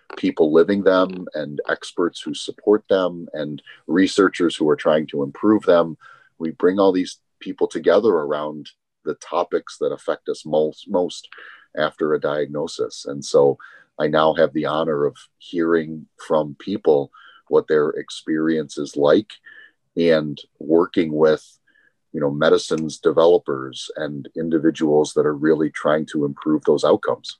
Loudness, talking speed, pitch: -20 LUFS, 145 wpm, 95 Hz